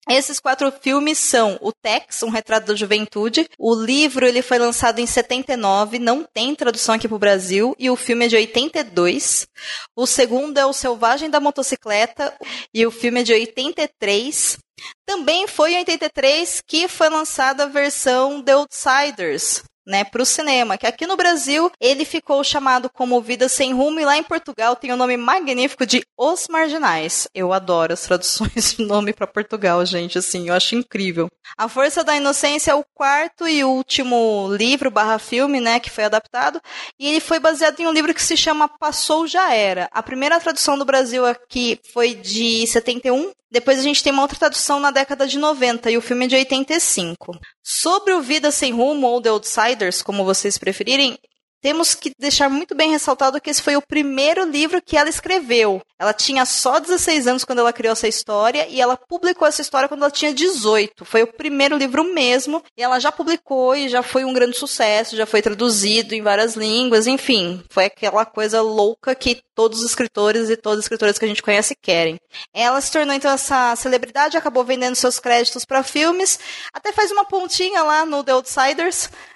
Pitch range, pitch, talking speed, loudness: 225-295 Hz, 260 Hz, 190 wpm, -18 LUFS